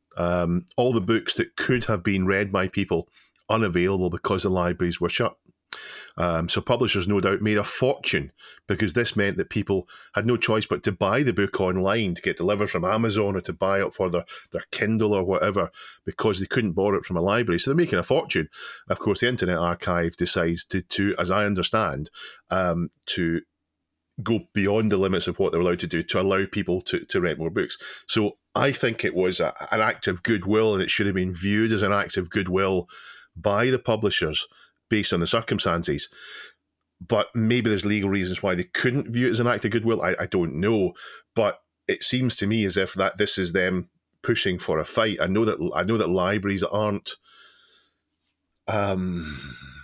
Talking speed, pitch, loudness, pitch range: 205 wpm, 100 Hz, -24 LUFS, 90-110 Hz